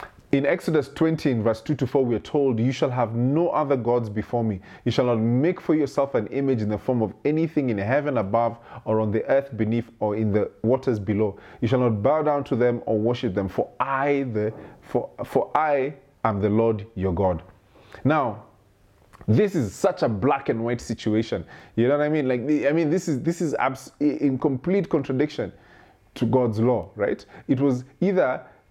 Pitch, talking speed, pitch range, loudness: 125 Hz, 205 wpm, 110-145 Hz, -24 LUFS